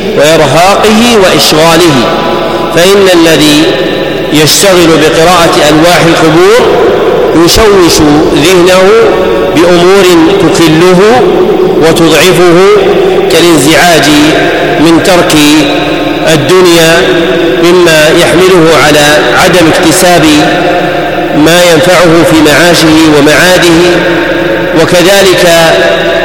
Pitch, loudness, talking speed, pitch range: 175 Hz, -3 LUFS, 65 wpm, 165-185 Hz